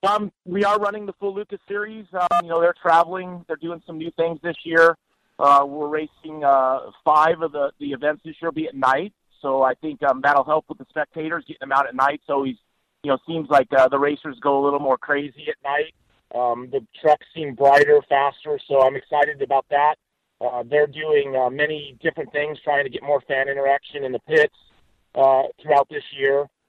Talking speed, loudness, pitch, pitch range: 220 wpm, -21 LUFS, 150 Hz, 140-165 Hz